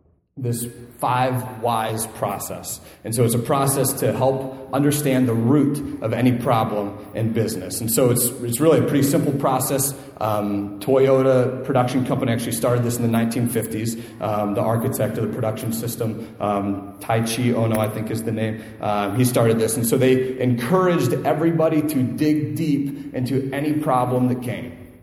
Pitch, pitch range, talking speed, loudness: 120 Hz, 110-135 Hz, 175 wpm, -21 LUFS